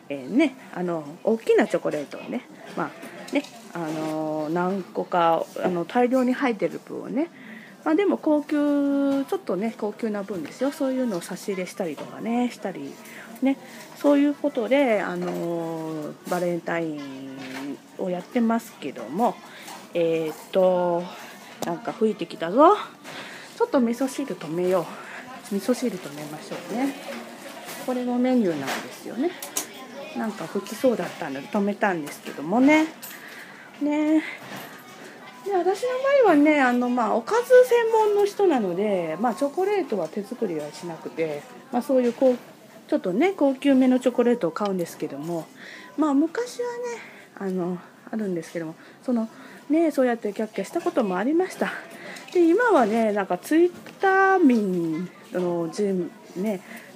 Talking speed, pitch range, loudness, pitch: 310 characters per minute, 180-285 Hz, -24 LUFS, 230 Hz